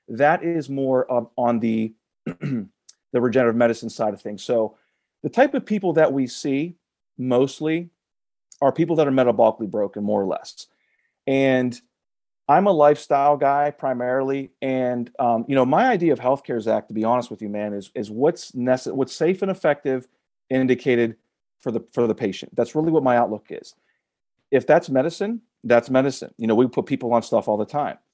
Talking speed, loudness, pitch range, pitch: 185 wpm, -21 LUFS, 120-145 Hz, 130 Hz